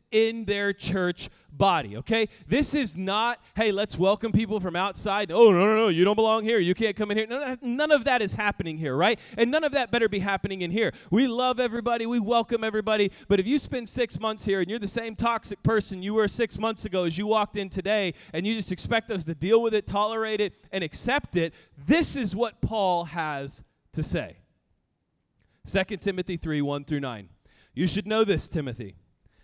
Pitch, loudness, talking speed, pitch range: 210 Hz, -26 LUFS, 210 wpm, 185-225 Hz